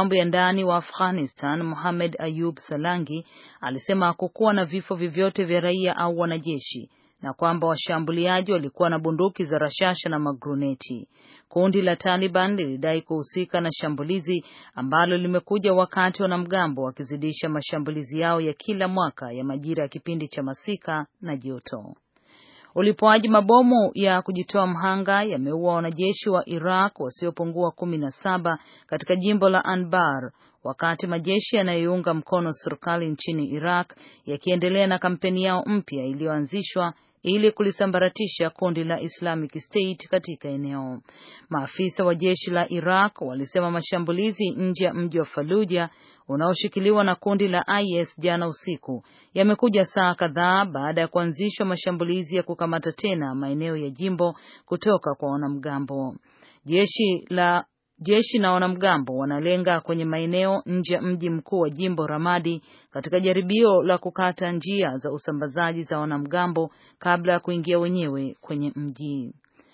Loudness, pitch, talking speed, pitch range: -24 LUFS, 175 Hz, 130 wpm, 155-185 Hz